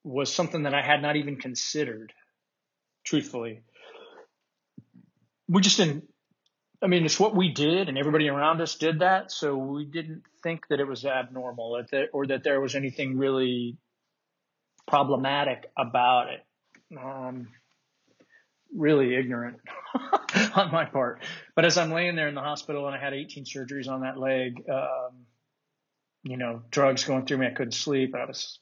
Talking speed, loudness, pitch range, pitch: 155 wpm, -26 LUFS, 130-160 Hz, 140 Hz